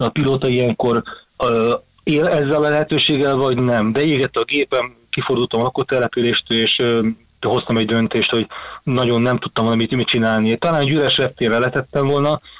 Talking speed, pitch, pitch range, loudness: 165 wpm, 125 Hz, 115-140 Hz, -17 LUFS